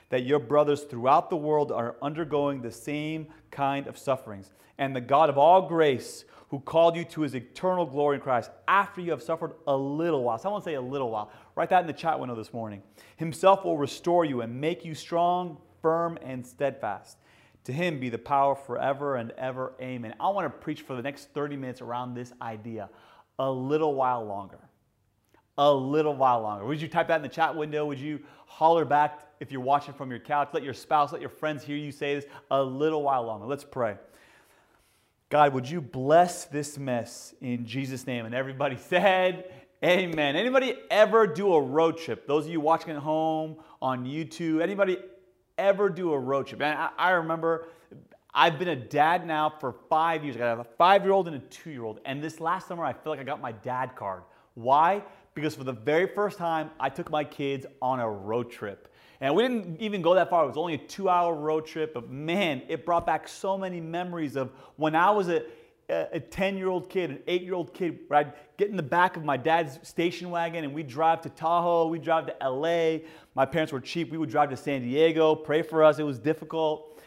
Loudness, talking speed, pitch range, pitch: -27 LUFS, 215 wpm, 135-165 Hz, 150 Hz